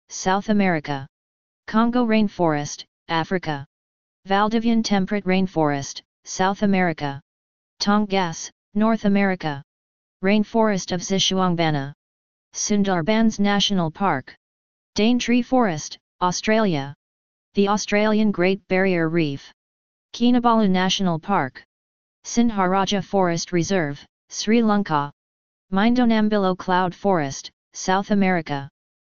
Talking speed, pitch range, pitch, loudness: 85 wpm, 145-205 Hz, 185 Hz, -21 LUFS